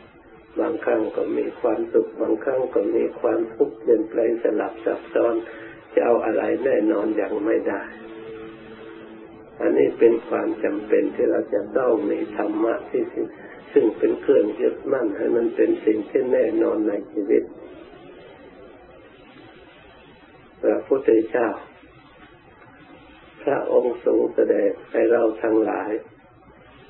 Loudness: -22 LUFS